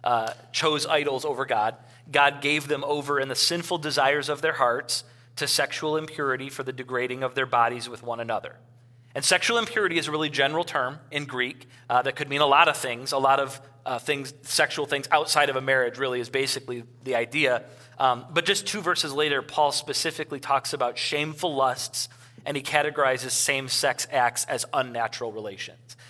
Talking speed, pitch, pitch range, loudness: 190 wpm, 140 Hz, 125-150 Hz, -25 LUFS